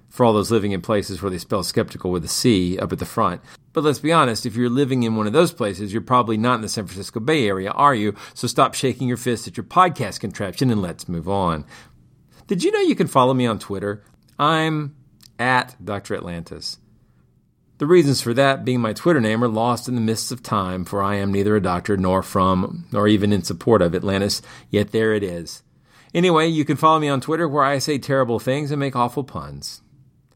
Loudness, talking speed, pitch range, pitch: -20 LUFS, 225 wpm, 100-135 Hz, 115 Hz